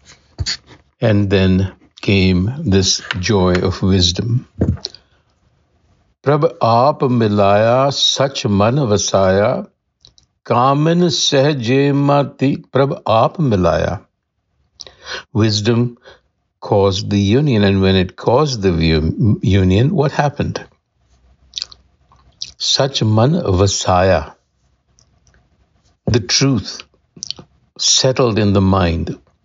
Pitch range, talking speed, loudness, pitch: 90-130 Hz, 75 wpm, -15 LUFS, 100 Hz